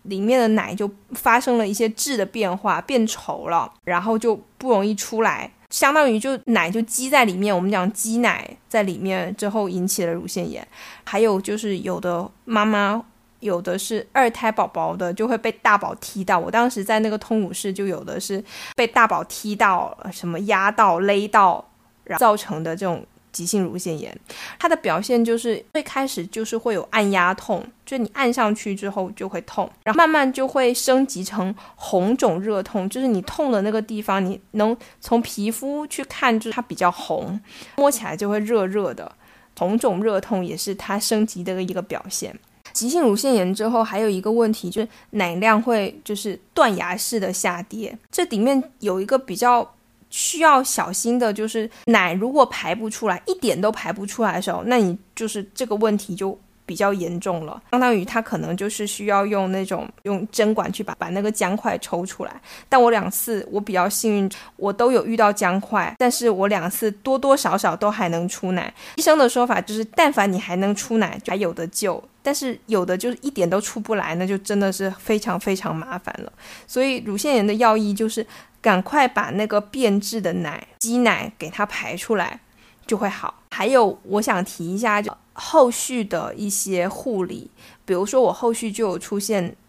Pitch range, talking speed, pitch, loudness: 195-230 Hz, 280 characters per minute, 210 Hz, -21 LUFS